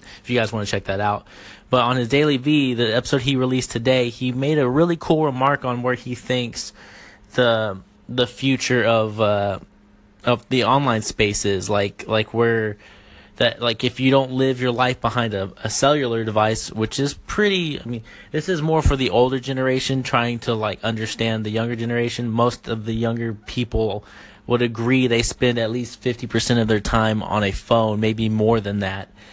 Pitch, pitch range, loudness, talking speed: 120 Hz, 110-130 Hz, -21 LUFS, 195 wpm